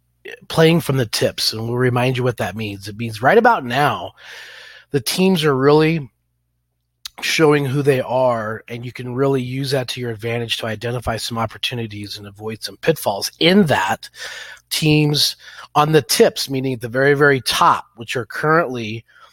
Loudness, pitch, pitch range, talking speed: -18 LUFS, 125 Hz, 110-145 Hz, 175 wpm